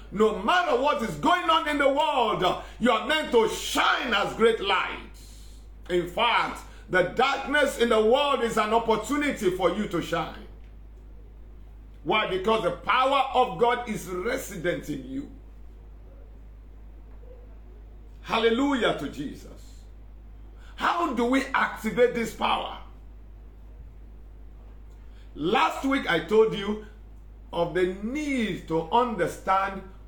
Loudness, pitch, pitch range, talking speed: -25 LUFS, 215 Hz, 160-260 Hz, 120 wpm